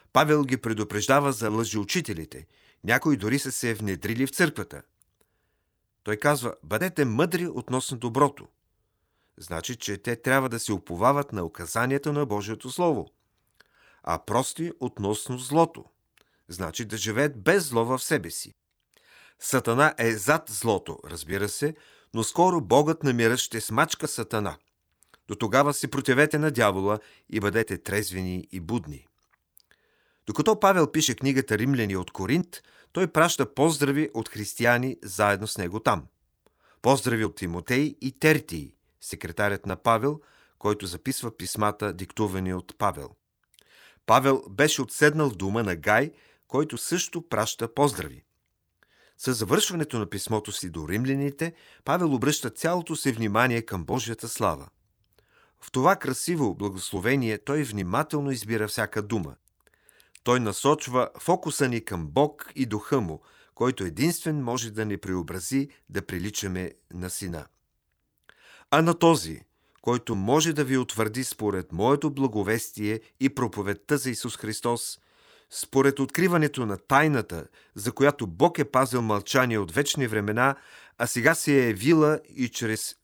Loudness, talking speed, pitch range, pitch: -26 LUFS, 135 wpm, 105-145 Hz, 120 Hz